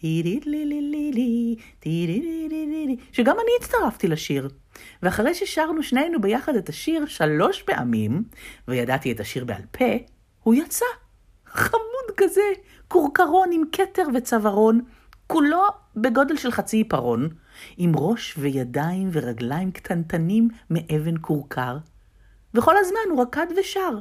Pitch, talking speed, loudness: 235 Hz, 105 wpm, -23 LUFS